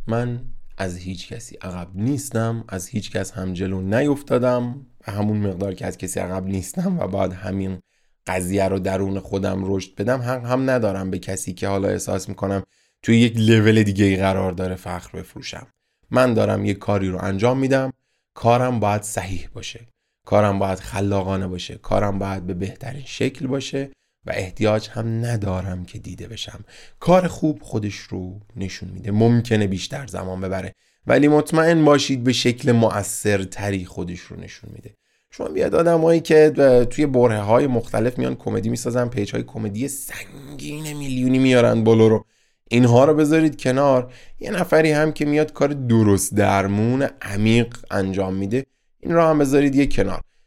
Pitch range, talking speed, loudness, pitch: 95-130 Hz, 160 wpm, -20 LUFS, 110 Hz